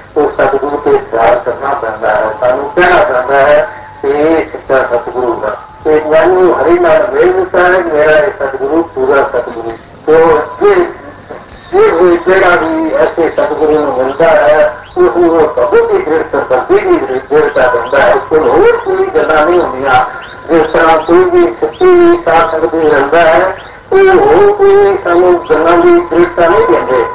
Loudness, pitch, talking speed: -9 LUFS, 200 Hz, 140 wpm